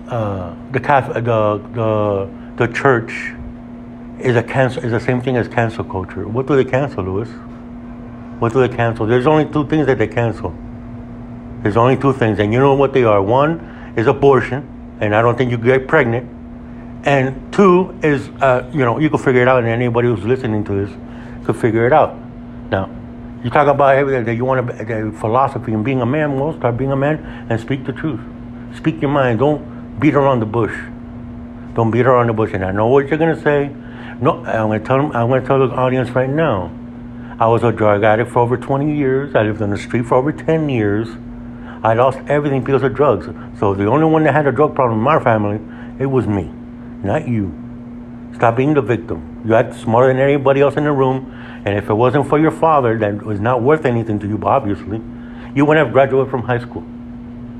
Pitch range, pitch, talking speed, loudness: 115-135 Hz, 120 Hz, 215 wpm, -16 LUFS